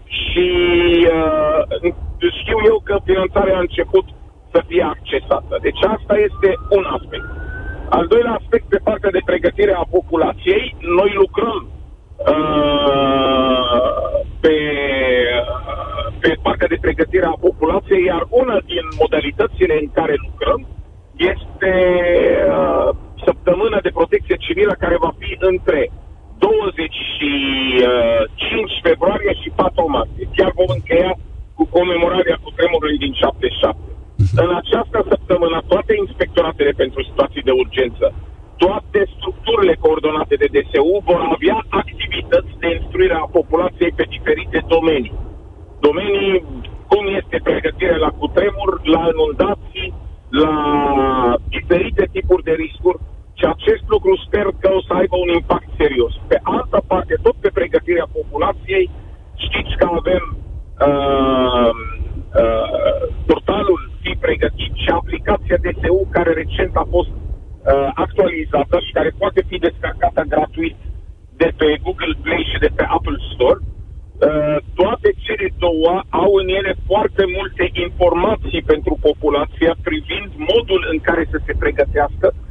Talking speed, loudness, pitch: 125 wpm, -16 LUFS, 190 Hz